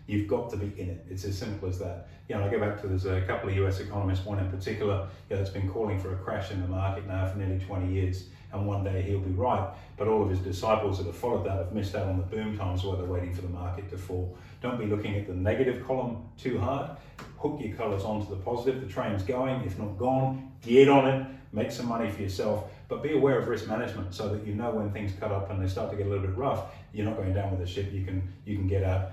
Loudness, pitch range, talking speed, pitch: -30 LUFS, 95-110 Hz, 280 wpm, 100 Hz